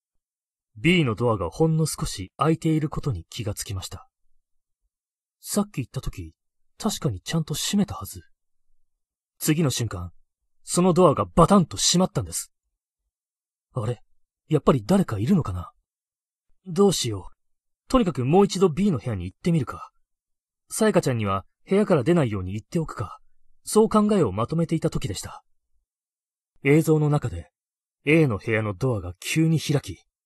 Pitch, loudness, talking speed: 140 Hz, -23 LUFS, 310 characters per minute